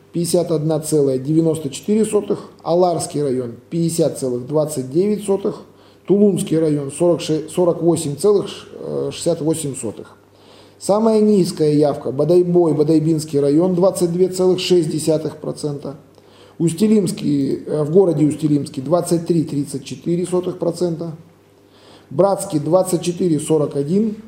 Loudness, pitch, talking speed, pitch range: -18 LUFS, 160 Hz, 50 wpm, 145-180 Hz